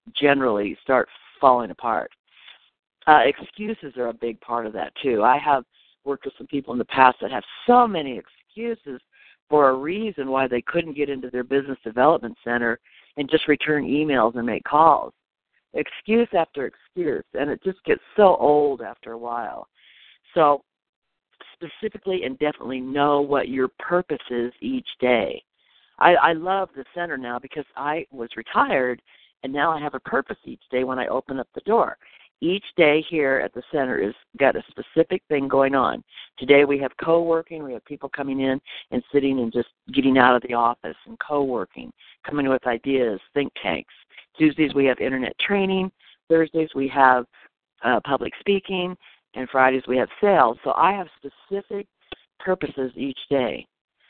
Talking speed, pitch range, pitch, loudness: 170 wpm, 130-170 Hz, 140 Hz, -22 LUFS